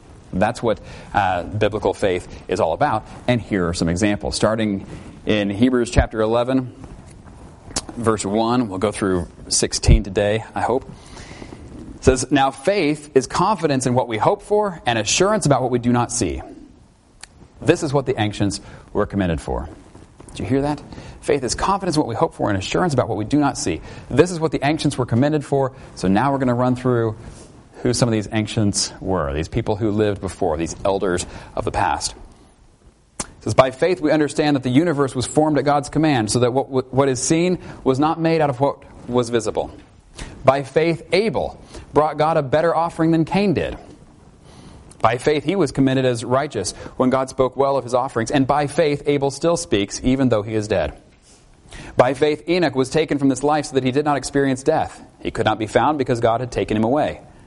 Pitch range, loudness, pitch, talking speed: 110-150 Hz, -20 LUFS, 130 Hz, 205 wpm